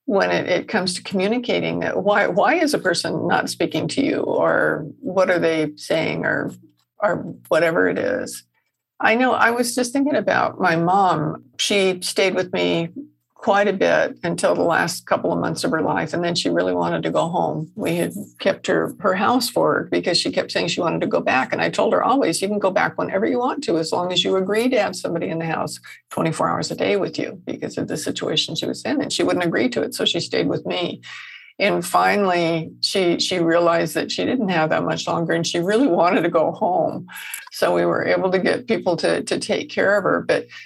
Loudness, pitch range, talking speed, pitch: -20 LUFS, 160-210 Hz, 230 wpm, 185 Hz